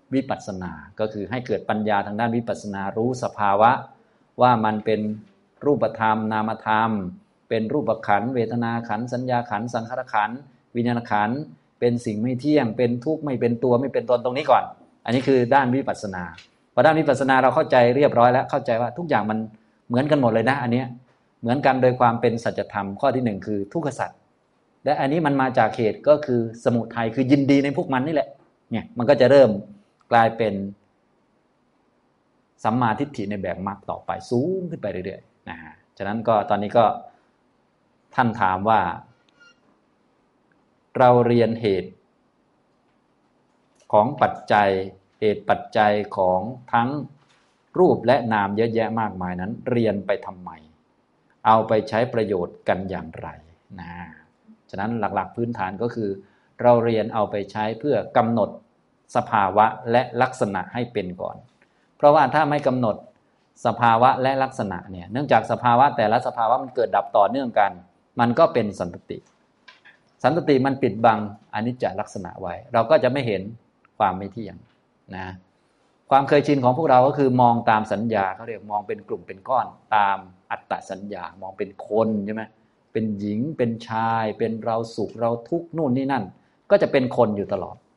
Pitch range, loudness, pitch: 105-125 Hz, -22 LUFS, 115 Hz